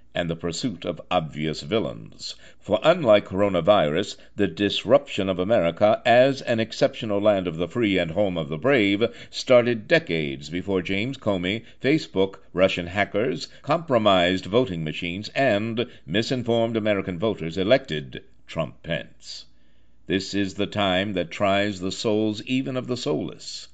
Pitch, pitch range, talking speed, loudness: 100 Hz, 90-110 Hz, 140 wpm, -23 LUFS